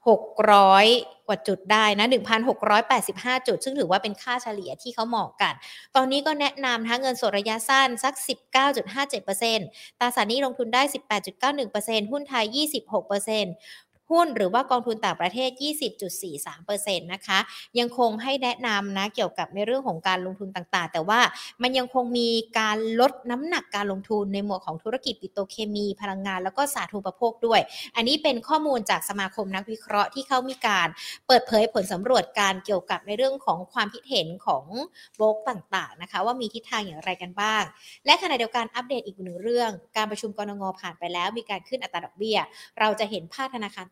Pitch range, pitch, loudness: 200-250 Hz, 220 Hz, -25 LUFS